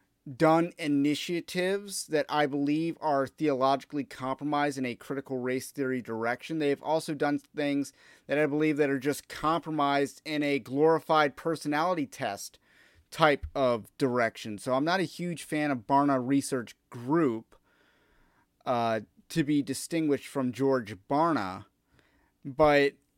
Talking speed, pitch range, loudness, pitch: 130 wpm, 135-155 Hz, -29 LUFS, 145 Hz